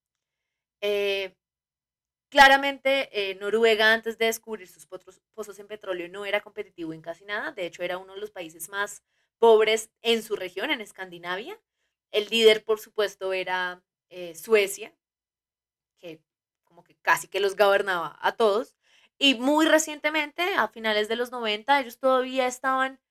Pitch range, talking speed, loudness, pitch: 185-230 Hz, 150 wpm, -24 LUFS, 210 Hz